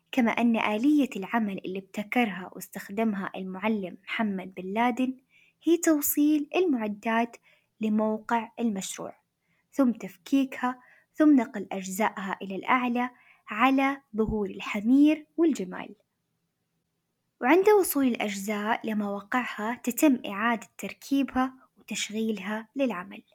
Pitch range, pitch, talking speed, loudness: 210-265 Hz, 230 Hz, 95 wpm, -27 LUFS